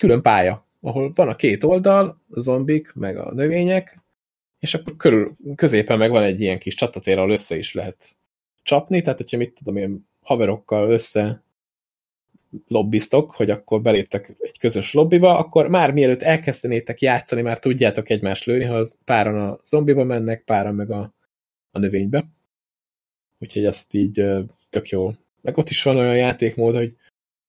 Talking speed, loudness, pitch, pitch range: 155 wpm, -20 LUFS, 120 Hz, 105-145 Hz